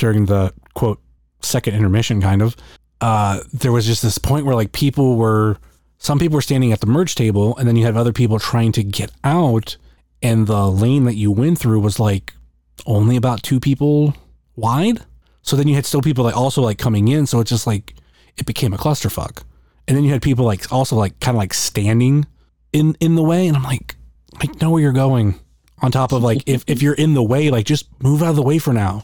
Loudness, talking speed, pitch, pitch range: -17 LUFS, 230 wpm, 115 Hz, 105-140 Hz